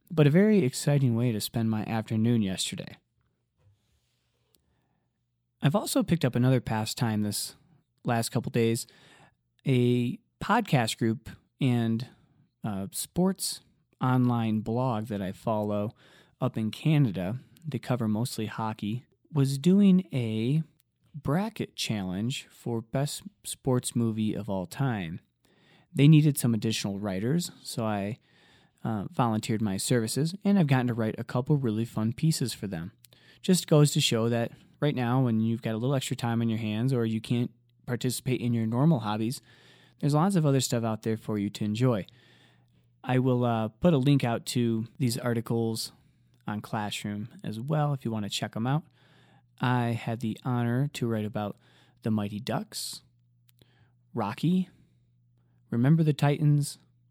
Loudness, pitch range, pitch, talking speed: -28 LUFS, 110-140 Hz, 120 Hz, 150 wpm